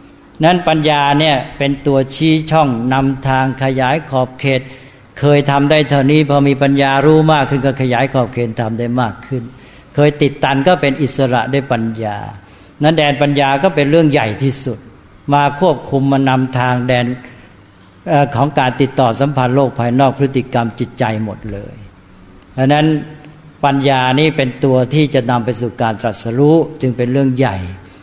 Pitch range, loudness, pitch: 125-145 Hz, -14 LUFS, 135 Hz